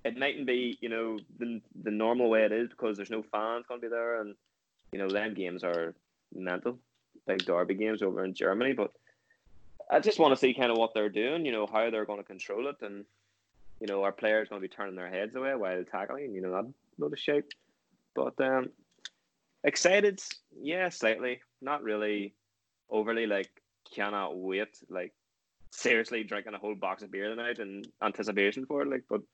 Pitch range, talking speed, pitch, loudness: 100-120 Hz, 190 wpm, 110 Hz, -31 LUFS